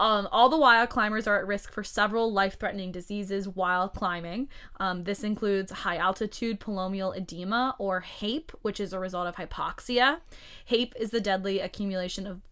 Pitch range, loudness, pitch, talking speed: 185-225 Hz, -28 LUFS, 200 Hz, 170 wpm